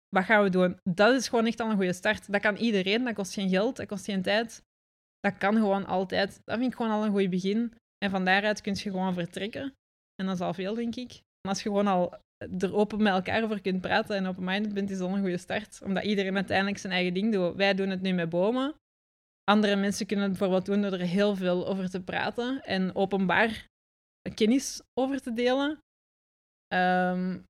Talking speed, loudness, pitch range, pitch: 225 wpm, -28 LUFS, 190-215 Hz, 200 Hz